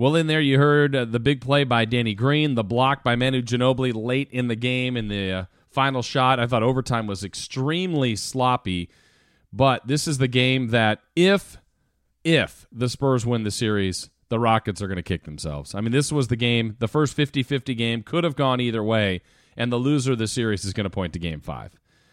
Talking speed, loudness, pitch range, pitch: 215 wpm, -23 LUFS, 110-135 Hz, 125 Hz